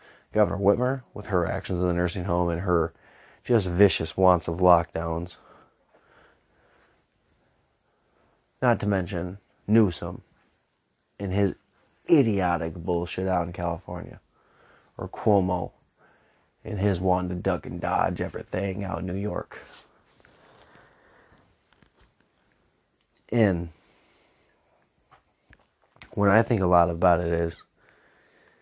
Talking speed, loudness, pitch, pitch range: 105 wpm, -25 LUFS, 90 Hz, 85-100 Hz